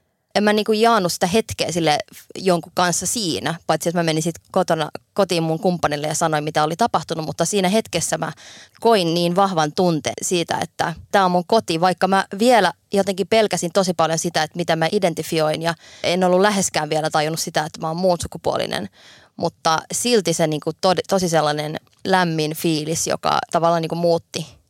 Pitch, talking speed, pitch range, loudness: 170 Hz, 180 wpm, 160-190 Hz, -20 LUFS